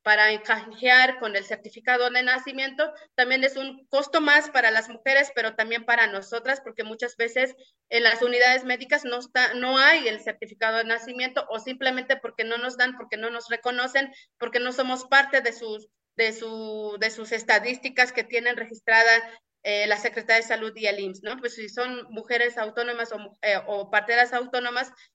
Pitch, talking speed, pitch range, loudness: 235 Hz, 185 wpm, 225-255 Hz, -23 LUFS